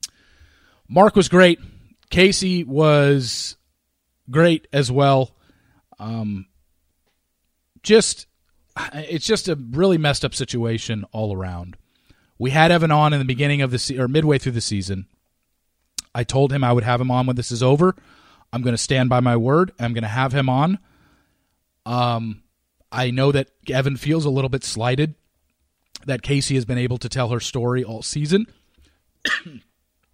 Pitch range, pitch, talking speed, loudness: 105-145 Hz, 125 Hz, 160 wpm, -19 LUFS